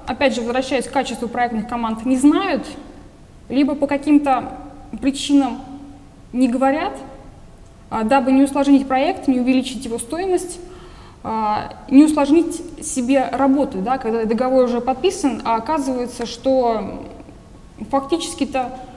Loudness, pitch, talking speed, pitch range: -19 LUFS, 265 Hz, 115 wpm, 245-280 Hz